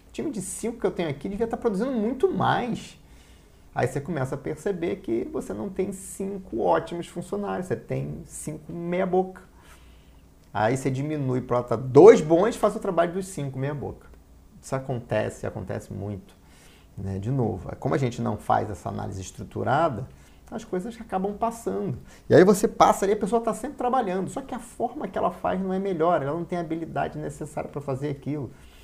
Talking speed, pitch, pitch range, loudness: 185 wpm, 160 Hz, 115-195 Hz, -25 LUFS